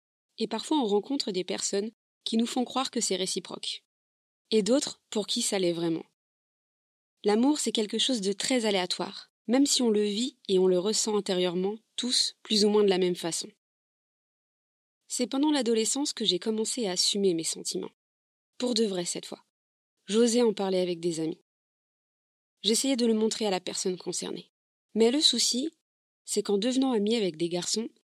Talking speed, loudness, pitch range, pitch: 180 wpm, -27 LUFS, 190-245 Hz, 215 Hz